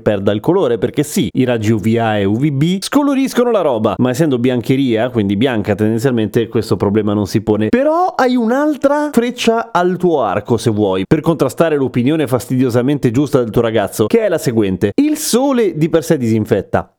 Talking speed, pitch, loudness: 180 wpm, 130 Hz, -14 LUFS